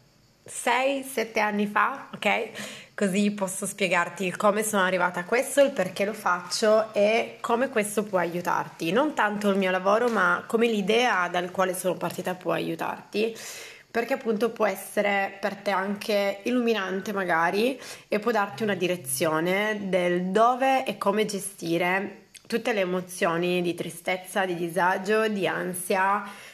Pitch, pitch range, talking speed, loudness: 200 Hz, 180-220 Hz, 140 wpm, -25 LUFS